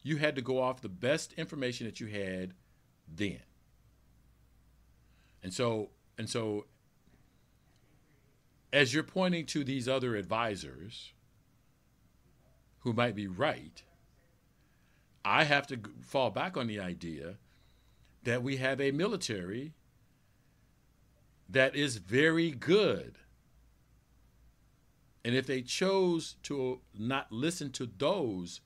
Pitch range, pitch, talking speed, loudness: 110-140 Hz, 130 Hz, 115 wpm, -33 LUFS